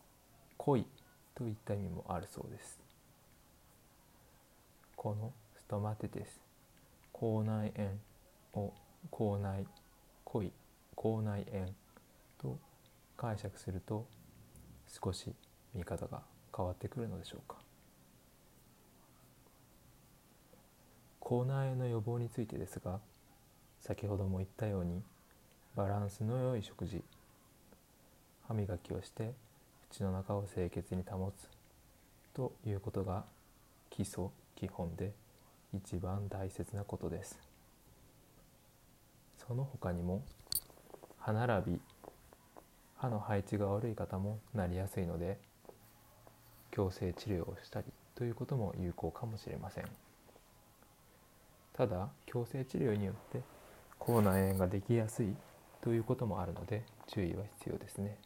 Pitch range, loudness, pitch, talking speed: 95-115 Hz, -40 LUFS, 100 Hz, 215 characters per minute